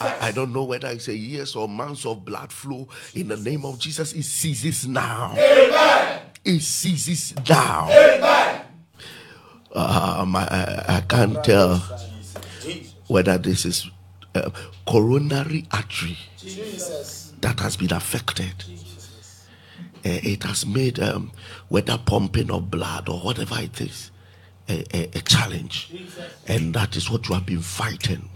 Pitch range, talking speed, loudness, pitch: 95-135 Hz, 135 wpm, -21 LUFS, 105 Hz